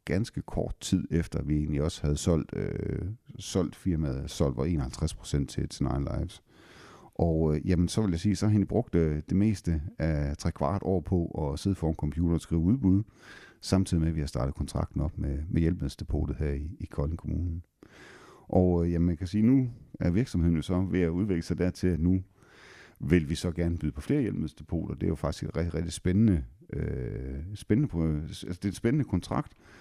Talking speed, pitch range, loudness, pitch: 195 wpm, 75-95 Hz, -29 LUFS, 85 Hz